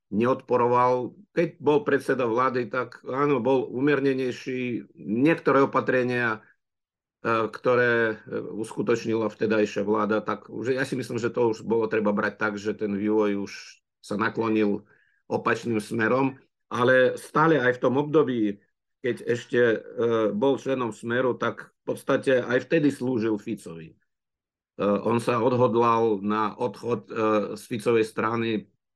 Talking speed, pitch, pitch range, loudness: 125 wpm, 120 Hz, 110-130 Hz, -25 LUFS